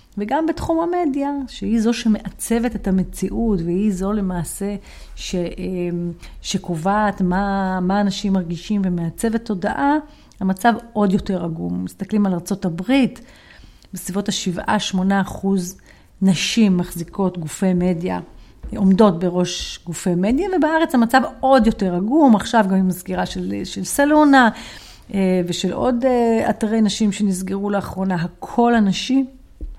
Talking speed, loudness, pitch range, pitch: 115 wpm, -19 LUFS, 185-230 Hz, 200 Hz